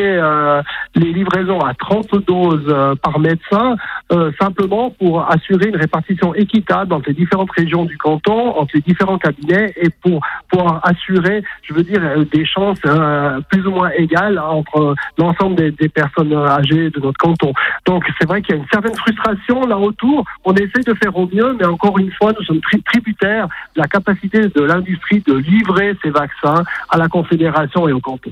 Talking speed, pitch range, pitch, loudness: 175 wpm, 155-200 Hz, 180 Hz, -15 LUFS